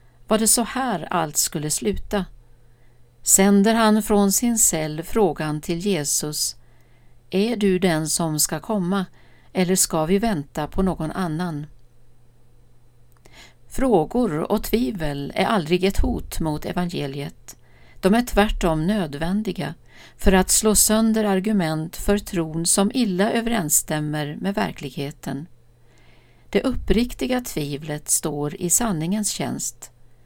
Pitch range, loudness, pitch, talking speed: 145-205 Hz, -21 LUFS, 170 Hz, 120 wpm